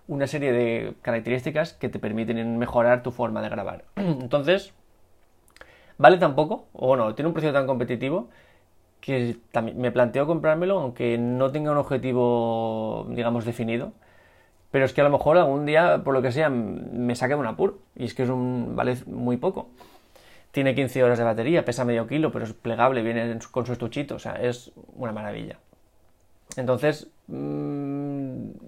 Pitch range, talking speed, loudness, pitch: 115-140 Hz, 170 wpm, -24 LUFS, 125 Hz